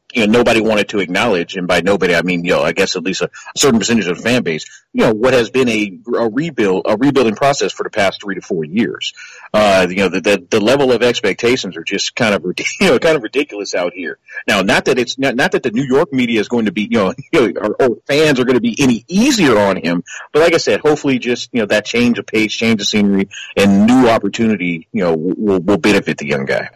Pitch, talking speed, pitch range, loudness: 110 Hz, 260 wpm, 100-120 Hz, -14 LUFS